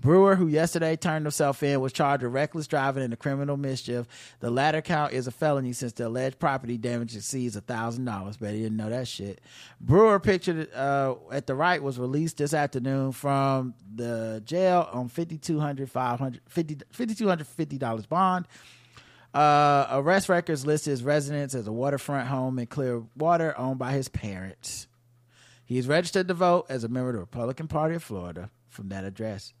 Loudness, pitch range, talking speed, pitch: -27 LUFS, 120-155 Hz, 175 wpm, 135 Hz